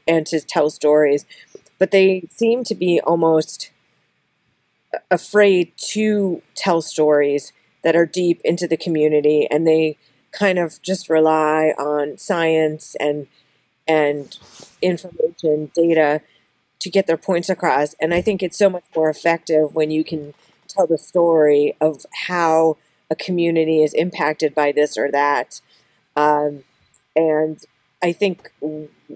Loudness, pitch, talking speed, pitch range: -18 LUFS, 160 Hz, 135 wpm, 150-175 Hz